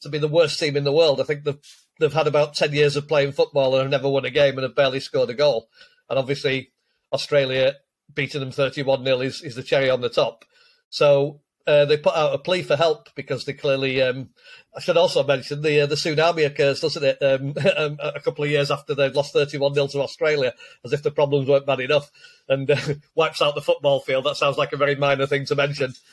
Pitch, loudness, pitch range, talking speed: 145 Hz, -21 LUFS, 140-160 Hz, 235 wpm